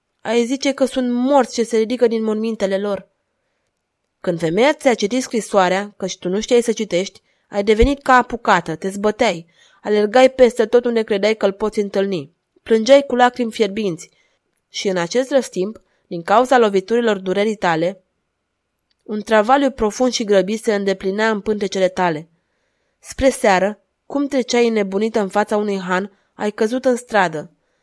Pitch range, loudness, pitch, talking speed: 195-240 Hz, -18 LUFS, 215 Hz, 160 wpm